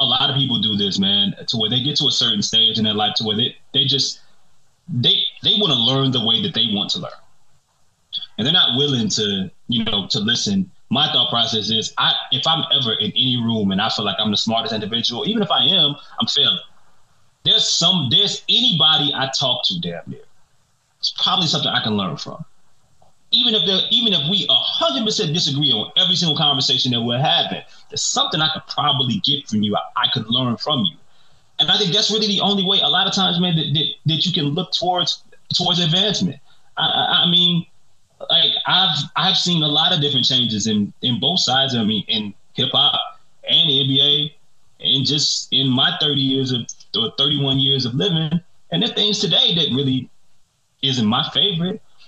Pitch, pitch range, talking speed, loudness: 145 Hz, 125-185 Hz, 210 wpm, -16 LUFS